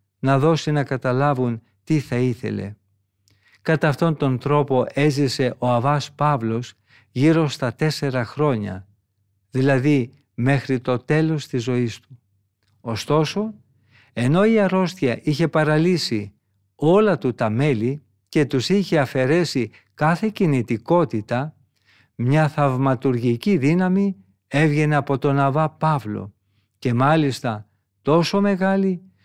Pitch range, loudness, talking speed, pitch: 115-155 Hz, -20 LUFS, 110 wpm, 135 Hz